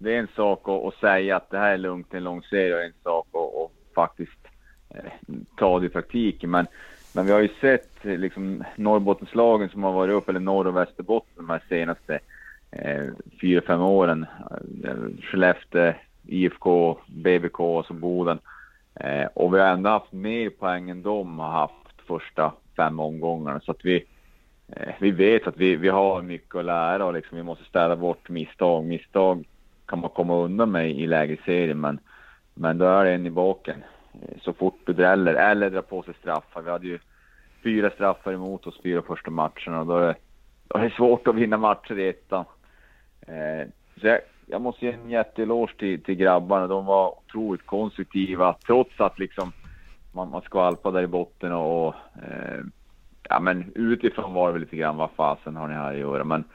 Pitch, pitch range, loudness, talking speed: 90 Hz, 85-100 Hz, -24 LUFS, 180 wpm